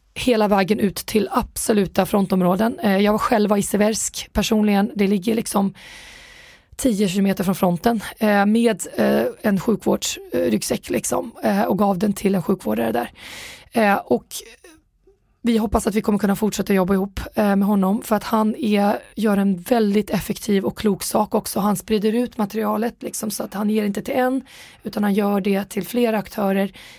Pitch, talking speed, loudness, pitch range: 210 Hz, 160 wpm, -20 LUFS, 200-225 Hz